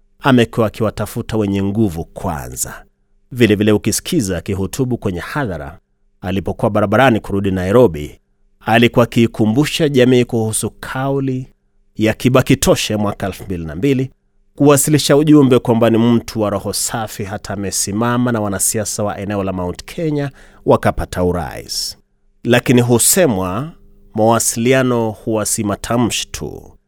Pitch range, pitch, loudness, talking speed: 100-120 Hz, 110 Hz, -15 LUFS, 105 wpm